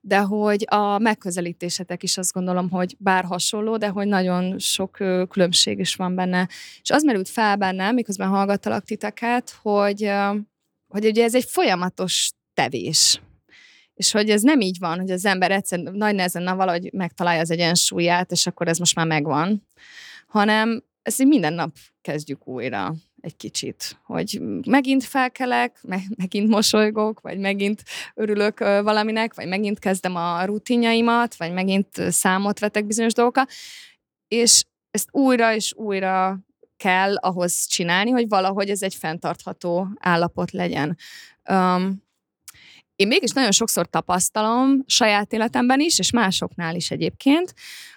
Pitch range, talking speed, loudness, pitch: 180-220 Hz, 140 wpm, -21 LUFS, 200 Hz